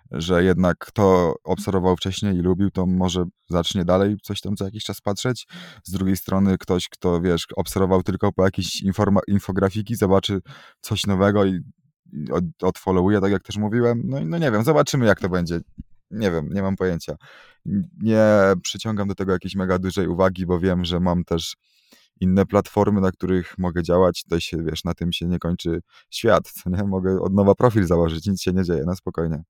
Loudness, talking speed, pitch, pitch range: -21 LUFS, 185 wpm, 95 Hz, 90-100 Hz